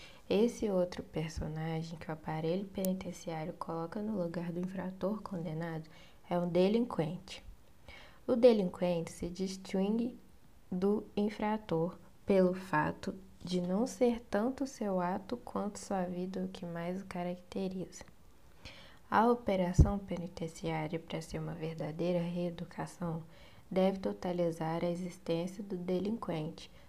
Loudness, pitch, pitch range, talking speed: -35 LUFS, 180 Hz, 170-200 Hz, 115 wpm